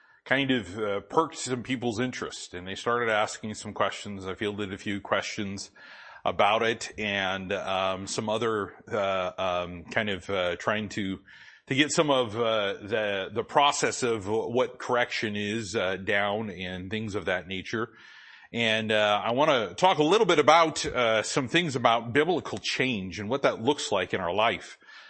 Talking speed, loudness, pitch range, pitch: 175 wpm, -27 LUFS, 100-120 Hz, 105 Hz